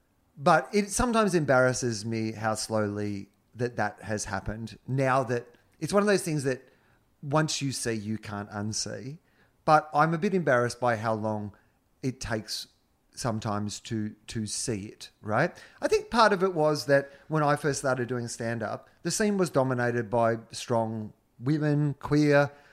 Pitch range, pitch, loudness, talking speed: 110-145 Hz, 120 Hz, -28 LUFS, 165 wpm